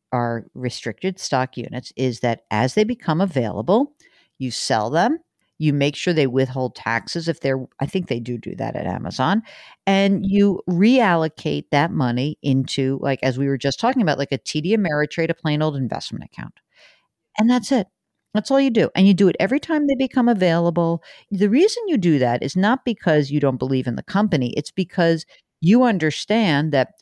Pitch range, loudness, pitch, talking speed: 135-205 Hz, -20 LUFS, 165 Hz, 190 wpm